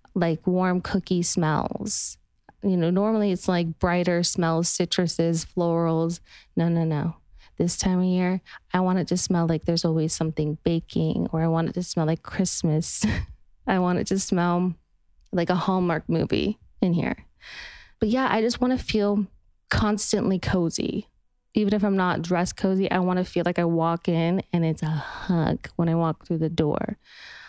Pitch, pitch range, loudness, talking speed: 175 Hz, 165-190 Hz, -24 LUFS, 180 wpm